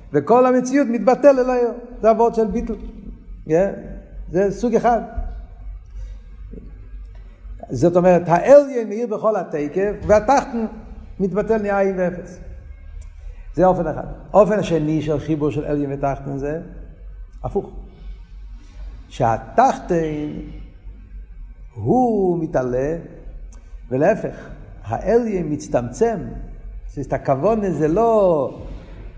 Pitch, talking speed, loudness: 170 Hz, 95 wpm, -19 LUFS